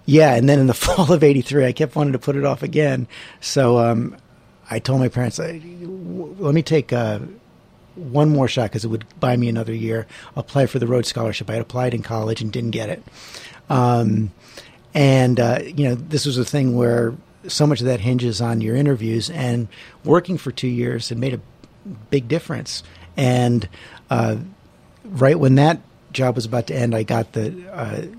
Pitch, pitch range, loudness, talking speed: 125 Hz, 115-145 Hz, -19 LUFS, 195 wpm